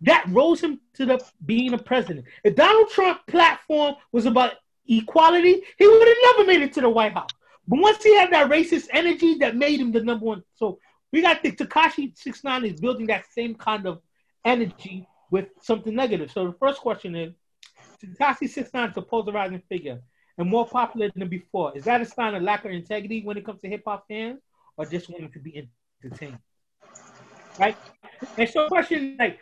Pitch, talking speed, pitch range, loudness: 235 Hz, 205 wpm, 200-290 Hz, -21 LUFS